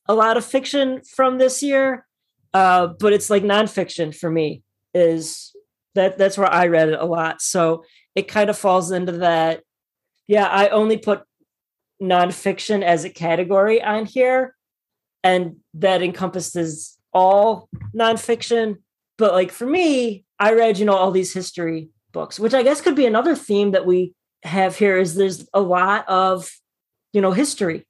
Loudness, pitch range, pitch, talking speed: -18 LUFS, 180-220 Hz, 195 Hz, 165 wpm